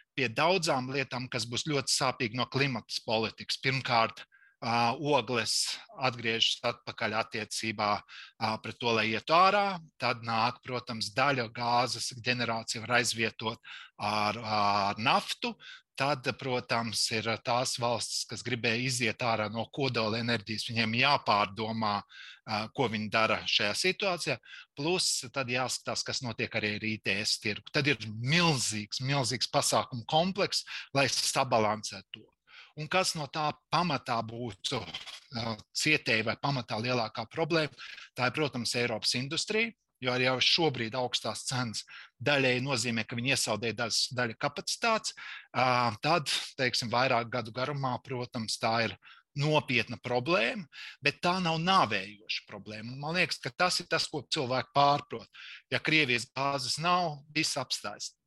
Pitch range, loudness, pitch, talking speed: 115-145 Hz, -30 LUFS, 125 Hz, 130 wpm